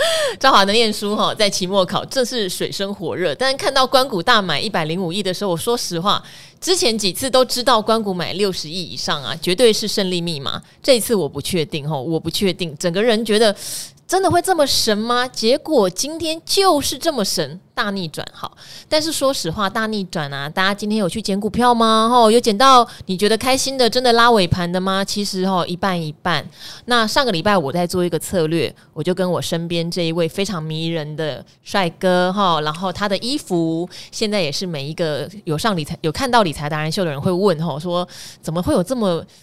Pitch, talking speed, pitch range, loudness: 195 Hz, 310 characters per minute, 170-230 Hz, -18 LUFS